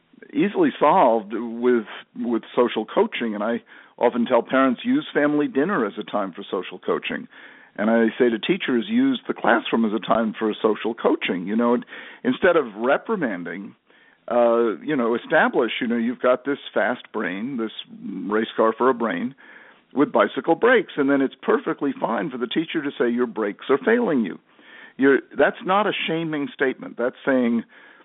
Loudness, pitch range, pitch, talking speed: -22 LUFS, 115-175 Hz, 125 Hz, 180 wpm